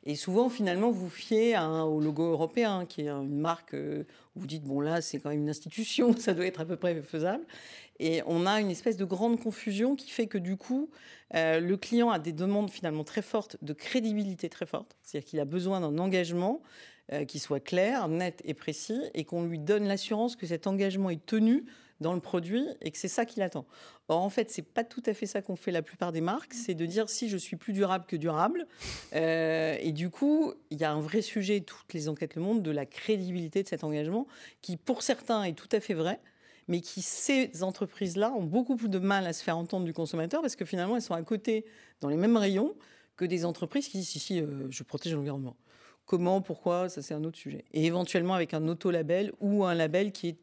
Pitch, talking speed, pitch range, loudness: 185 Hz, 235 wpm, 160-220 Hz, -31 LUFS